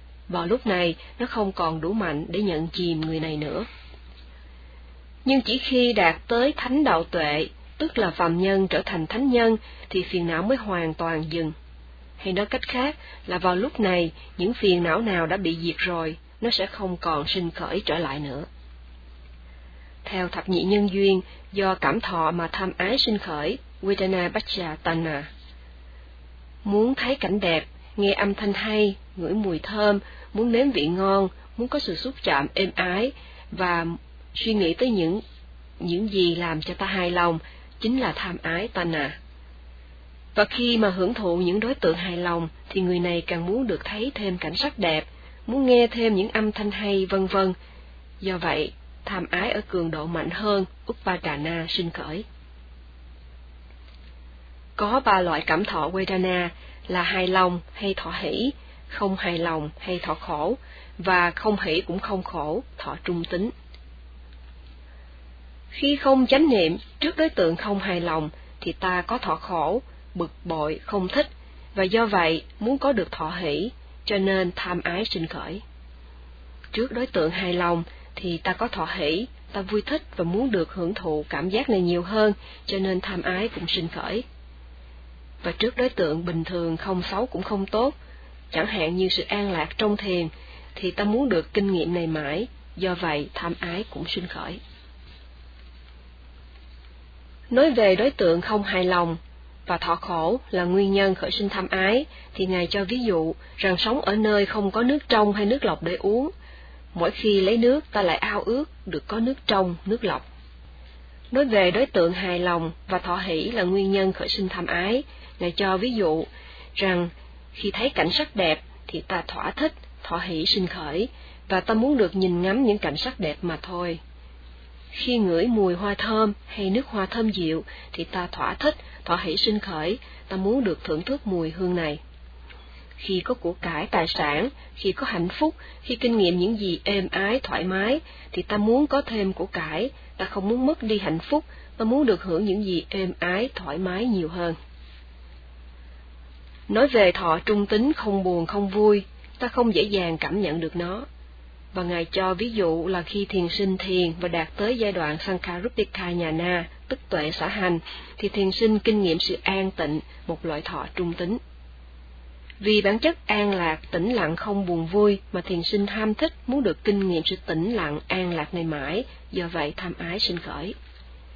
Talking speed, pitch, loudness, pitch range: 185 wpm, 180 Hz, -24 LUFS, 160-205 Hz